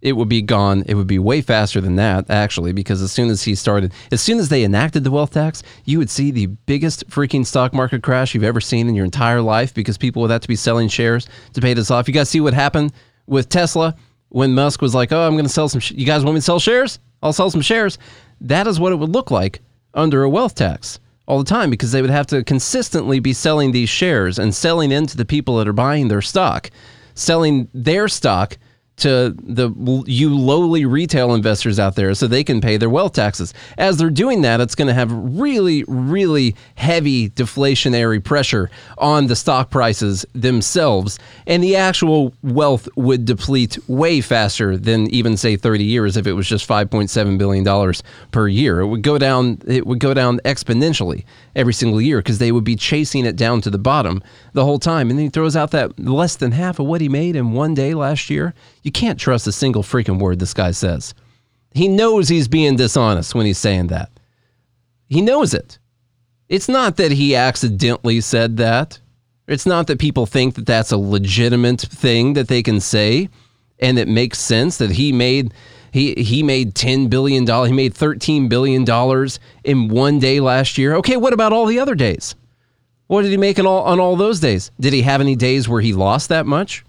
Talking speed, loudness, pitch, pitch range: 215 wpm, -16 LUFS, 125 Hz, 115-145 Hz